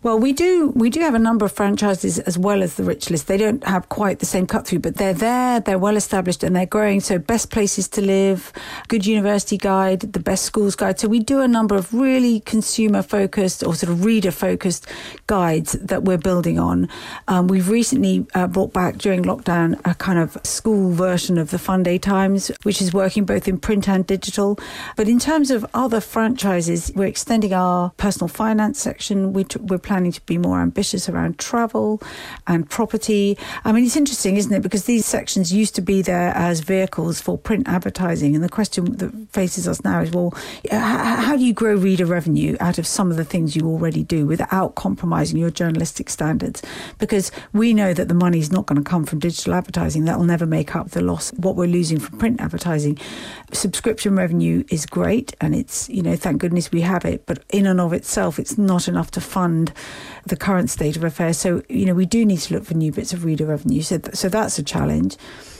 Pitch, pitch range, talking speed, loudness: 190 Hz, 175-215 Hz, 215 wpm, -19 LUFS